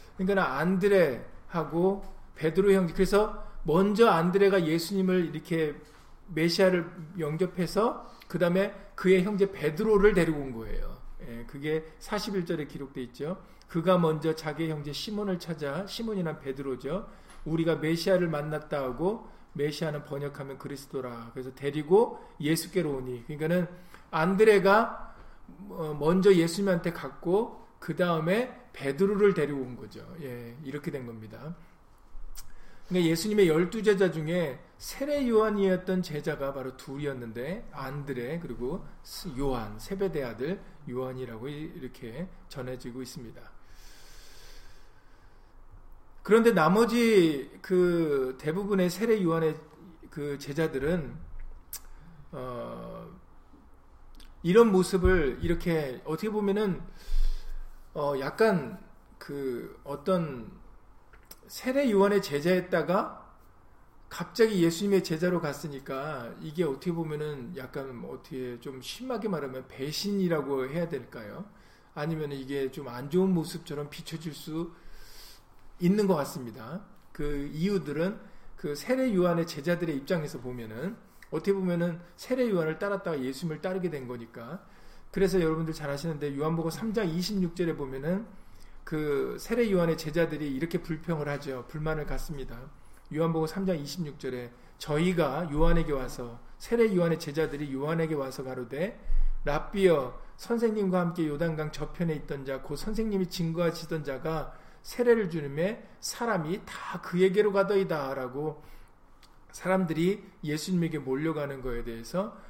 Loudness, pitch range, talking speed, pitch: -29 LUFS, 145-190 Hz, 290 characters per minute, 165 Hz